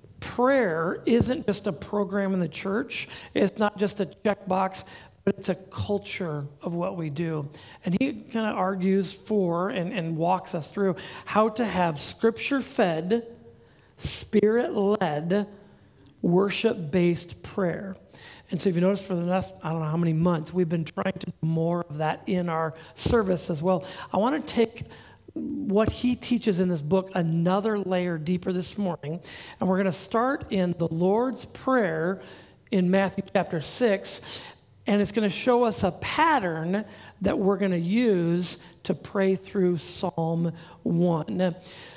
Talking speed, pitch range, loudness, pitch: 165 wpm, 175-205 Hz, -26 LUFS, 190 Hz